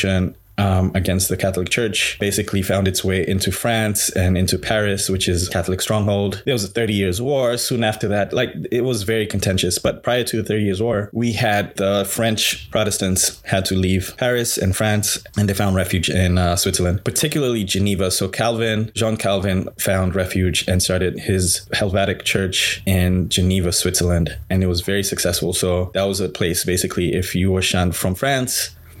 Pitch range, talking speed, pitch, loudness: 95-110 Hz, 185 wpm, 95 Hz, -19 LUFS